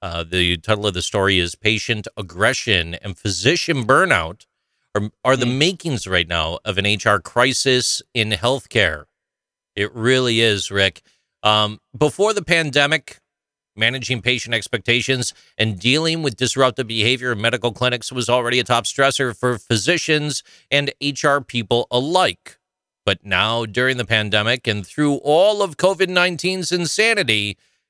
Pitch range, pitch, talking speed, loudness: 105-140 Hz, 120 Hz, 140 wpm, -18 LUFS